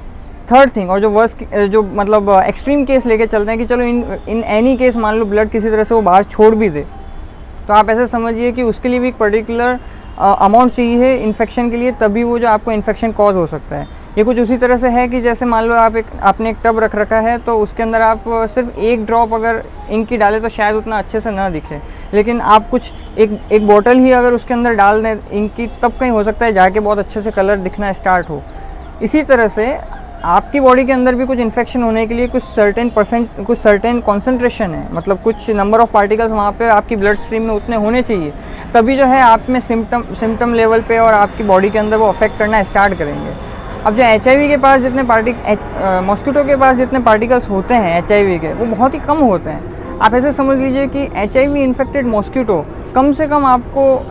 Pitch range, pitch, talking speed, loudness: 210-245 Hz, 225 Hz, 225 wpm, -13 LUFS